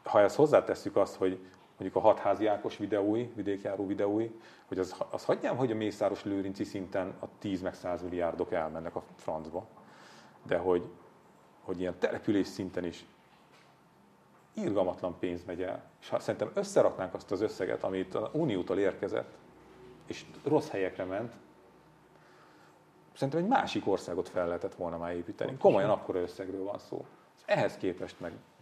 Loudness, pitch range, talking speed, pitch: -32 LUFS, 90-100 Hz, 150 wpm, 95 Hz